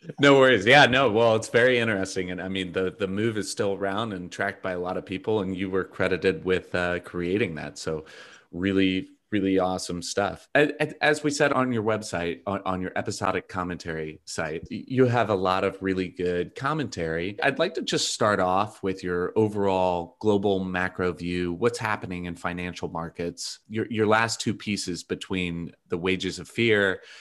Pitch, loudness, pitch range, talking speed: 95 Hz, -25 LUFS, 90-110 Hz, 185 wpm